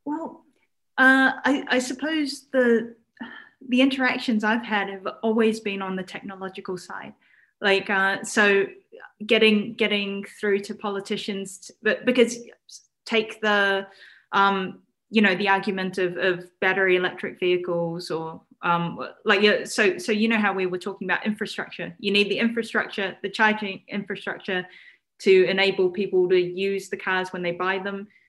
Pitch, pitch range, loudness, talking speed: 200 Hz, 190-225 Hz, -23 LUFS, 150 wpm